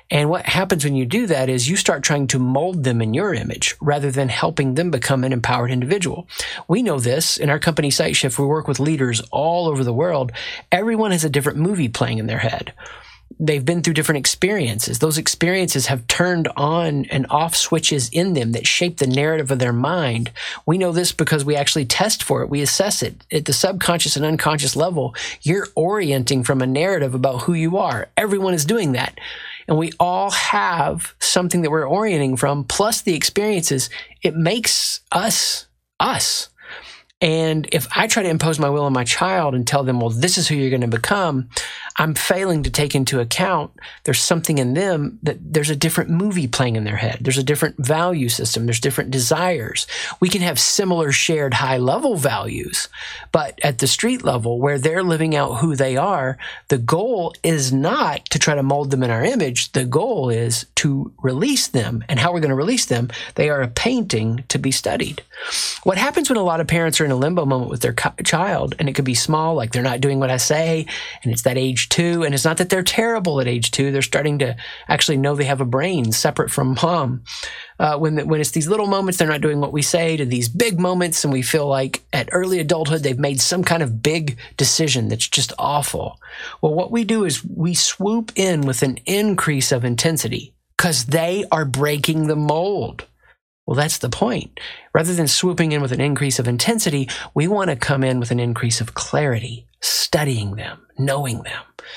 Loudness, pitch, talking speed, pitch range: -19 LUFS, 150 Hz, 205 wpm, 130-170 Hz